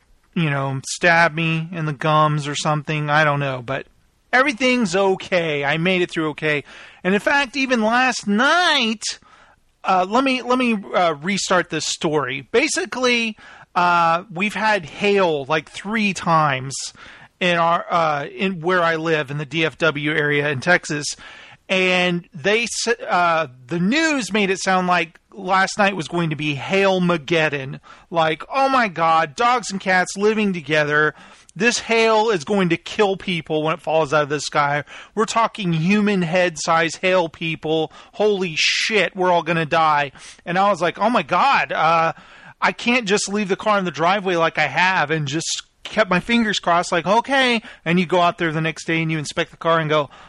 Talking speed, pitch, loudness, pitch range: 185 wpm, 175 Hz, -19 LUFS, 160-205 Hz